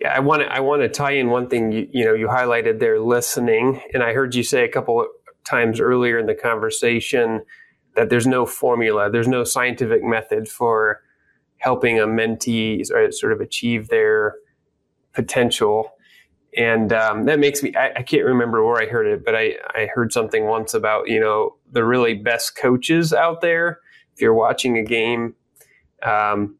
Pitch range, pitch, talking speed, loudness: 115-170 Hz, 125 Hz, 180 wpm, -19 LUFS